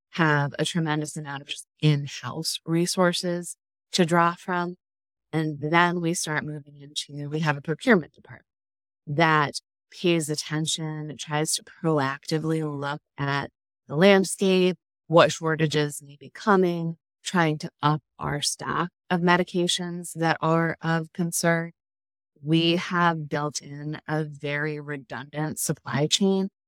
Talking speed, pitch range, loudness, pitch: 125 wpm, 150-170 Hz, -25 LUFS, 155 Hz